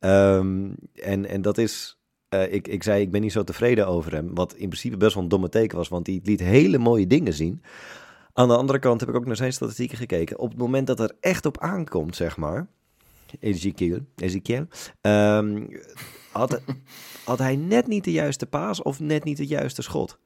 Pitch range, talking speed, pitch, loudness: 95-130 Hz, 205 wpm, 110 Hz, -24 LUFS